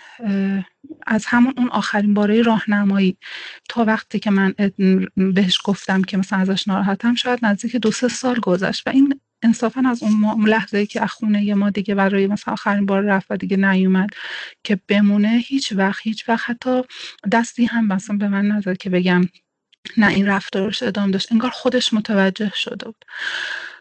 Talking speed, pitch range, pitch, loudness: 170 wpm, 195-235 Hz, 210 Hz, -19 LUFS